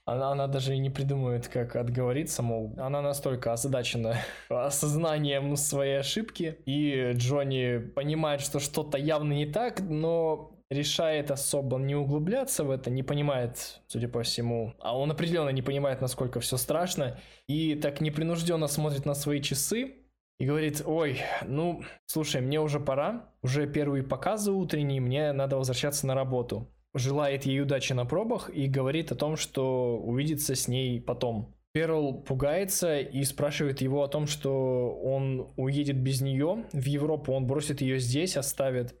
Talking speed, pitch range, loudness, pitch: 155 wpm, 130-150 Hz, -30 LUFS, 140 Hz